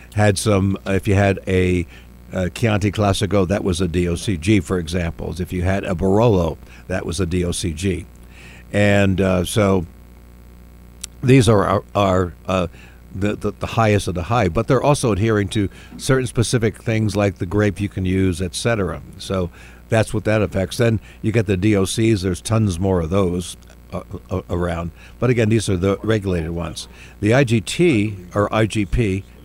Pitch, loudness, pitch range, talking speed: 95 Hz, -19 LUFS, 90-105 Hz, 170 wpm